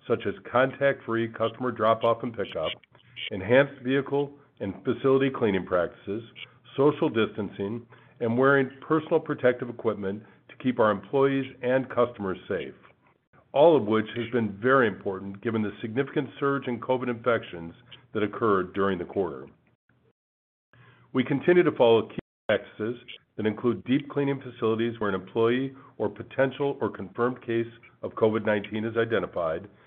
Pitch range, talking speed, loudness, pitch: 110-135 Hz, 145 wpm, -27 LUFS, 120 Hz